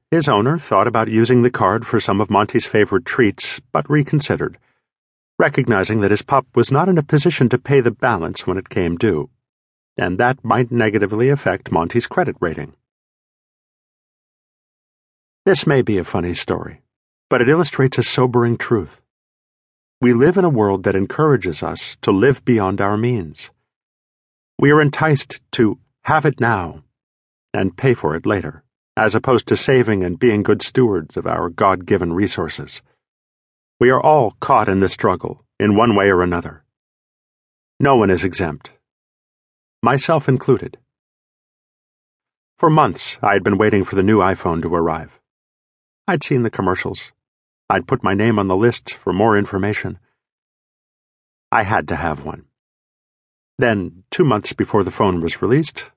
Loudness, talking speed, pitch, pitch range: -17 LUFS, 160 wpm, 110 Hz, 90-130 Hz